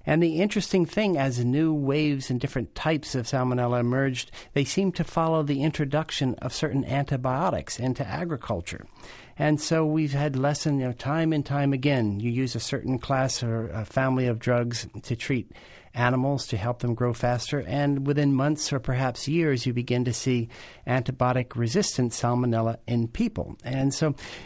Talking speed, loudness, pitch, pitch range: 170 wpm, -26 LUFS, 130 Hz, 120-145 Hz